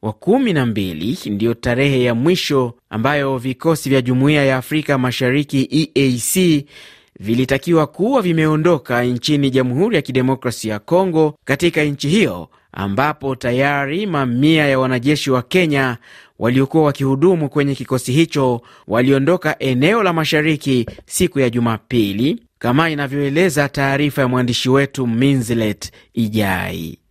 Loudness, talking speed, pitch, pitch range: -17 LUFS, 120 wpm, 135 Hz, 120-150 Hz